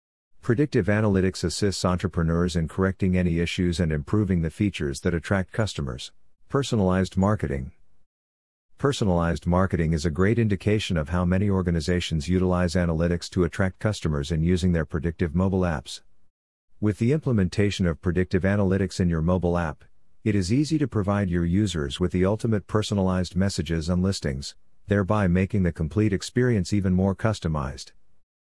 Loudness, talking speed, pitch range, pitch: -25 LUFS, 150 wpm, 85-100 Hz, 90 Hz